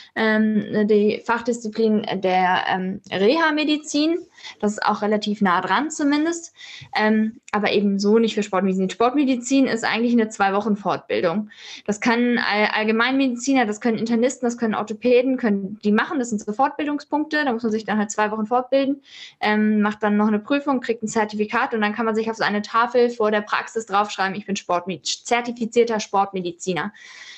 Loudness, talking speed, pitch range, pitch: -21 LUFS, 165 wpm, 210-250 Hz, 220 Hz